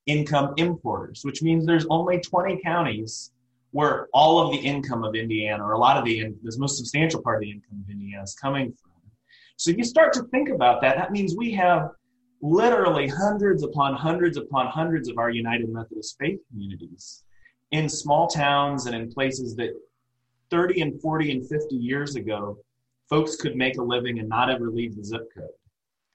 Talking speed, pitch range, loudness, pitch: 190 wpm, 115-160 Hz, -24 LUFS, 135 Hz